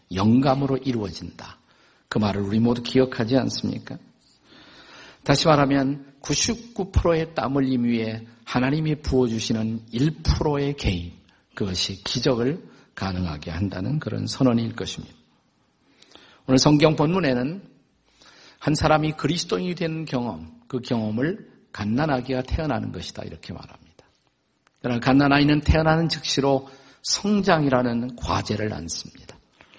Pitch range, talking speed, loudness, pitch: 110-145 Hz, 280 characters per minute, -23 LUFS, 130 Hz